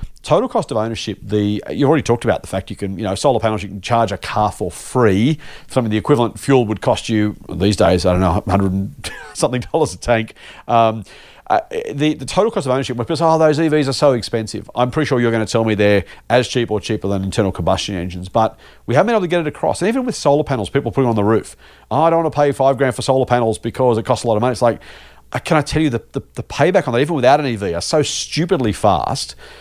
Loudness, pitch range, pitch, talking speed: -17 LUFS, 105-140 Hz, 115 Hz, 270 wpm